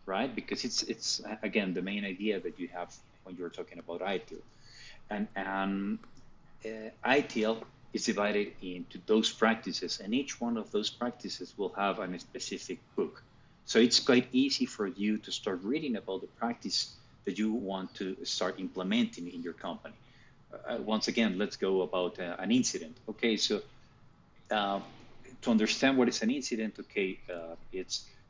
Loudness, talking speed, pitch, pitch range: -33 LUFS, 170 wpm, 110 Hz, 95-120 Hz